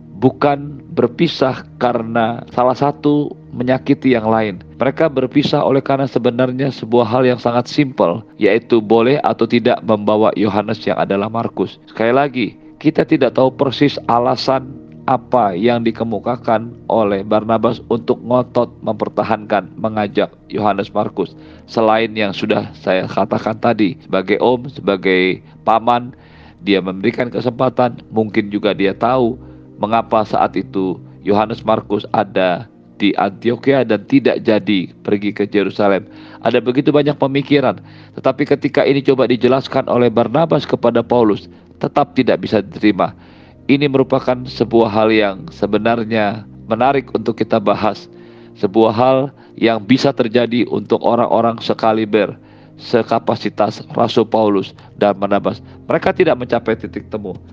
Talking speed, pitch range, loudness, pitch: 125 wpm, 105-130 Hz, -16 LUFS, 115 Hz